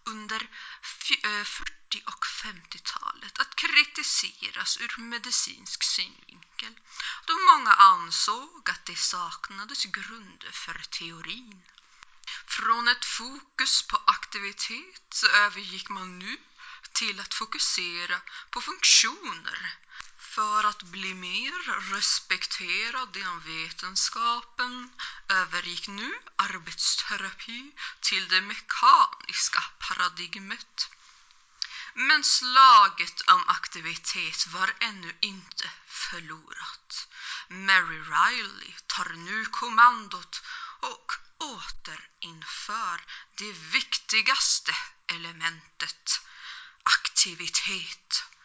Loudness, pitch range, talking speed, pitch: -26 LUFS, 185-250 Hz, 80 wpm, 210 Hz